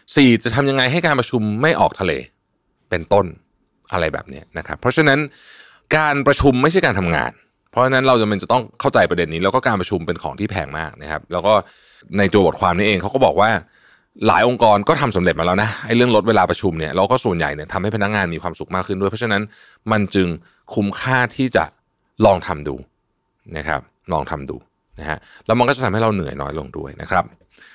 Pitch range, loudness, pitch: 90-125 Hz, -18 LUFS, 105 Hz